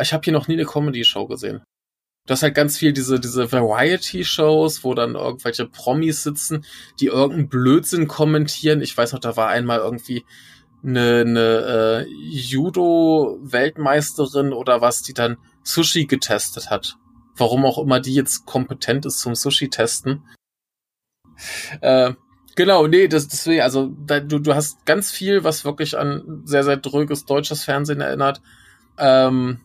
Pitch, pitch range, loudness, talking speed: 140 Hz, 125-150 Hz, -19 LUFS, 150 wpm